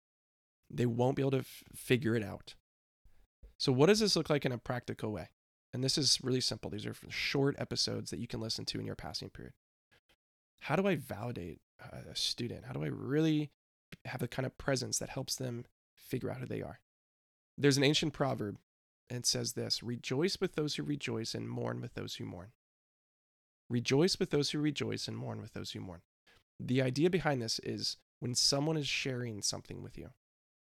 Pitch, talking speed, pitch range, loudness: 125 Hz, 200 wpm, 105-140 Hz, -34 LUFS